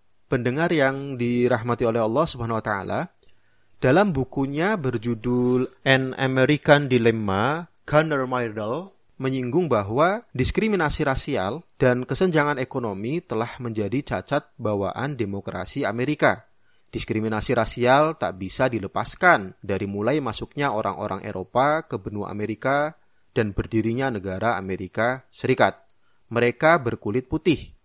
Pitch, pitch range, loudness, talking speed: 125 Hz, 110-140 Hz, -23 LUFS, 110 wpm